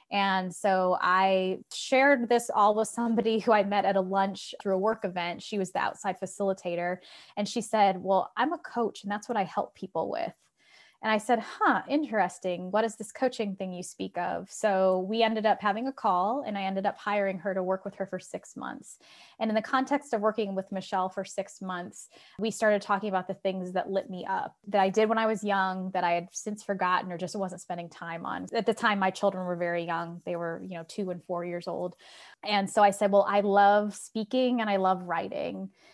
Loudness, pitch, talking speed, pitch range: -29 LUFS, 195 Hz, 230 wpm, 185-215 Hz